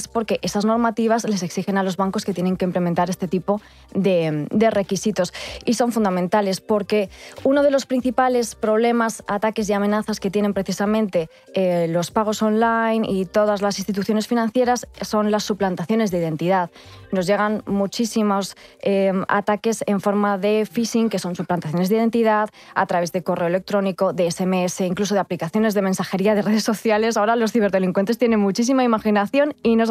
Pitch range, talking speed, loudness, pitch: 190-225 Hz, 165 wpm, -21 LUFS, 205 Hz